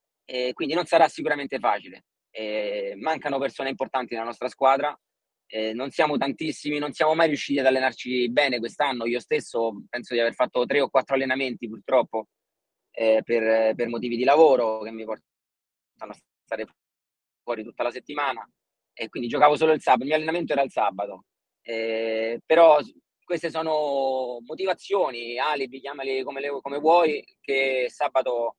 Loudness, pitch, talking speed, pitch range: -24 LUFS, 130 Hz, 160 wpm, 115-150 Hz